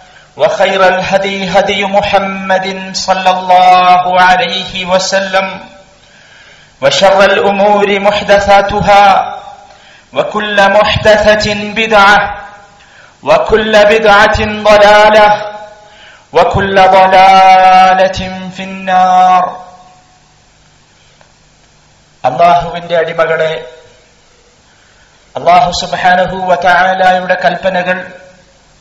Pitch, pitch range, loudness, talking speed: 190 Hz, 185-205 Hz, -8 LUFS, 55 wpm